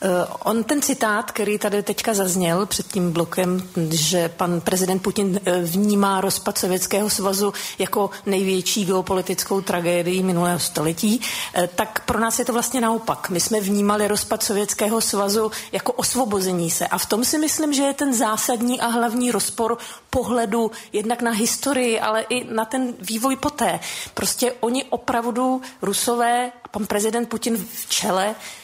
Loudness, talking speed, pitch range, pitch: -21 LUFS, 150 wpm, 190-235 Hz, 215 Hz